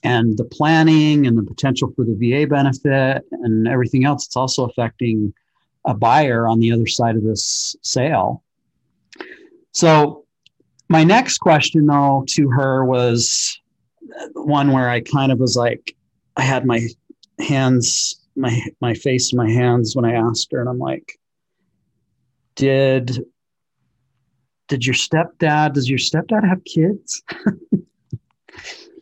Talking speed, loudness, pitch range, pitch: 135 wpm, -17 LUFS, 120-150 Hz, 130 Hz